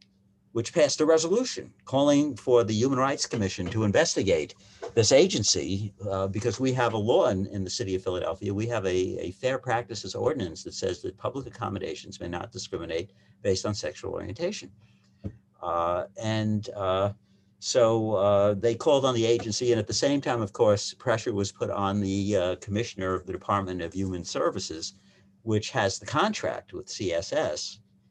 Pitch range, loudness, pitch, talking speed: 95-120 Hz, -27 LUFS, 105 Hz, 175 wpm